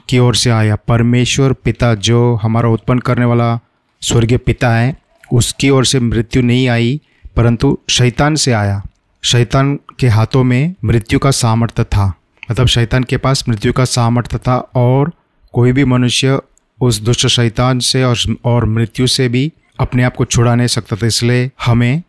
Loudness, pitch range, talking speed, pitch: -13 LUFS, 115-130 Hz, 170 wpm, 125 Hz